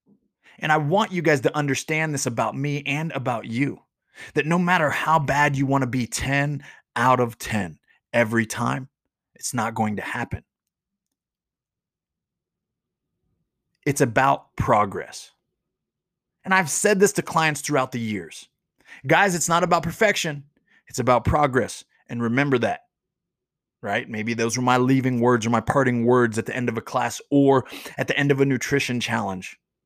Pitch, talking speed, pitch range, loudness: 140 Hz, 165 wpm, 125-160 Hz, -22 LUFS